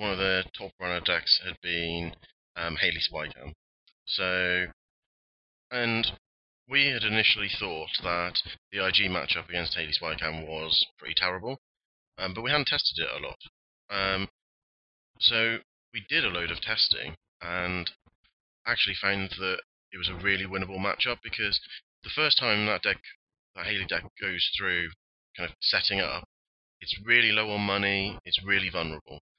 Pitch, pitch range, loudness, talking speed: 95 Hz, 85-100 Hz, -27 LUFS, 155 wpm